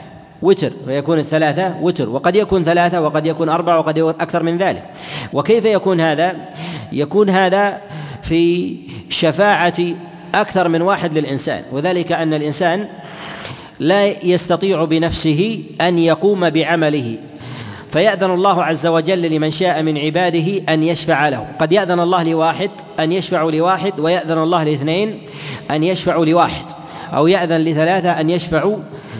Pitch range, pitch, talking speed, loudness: 155-180 Hz, 170 Hz, 130 wpm, -16 LUFS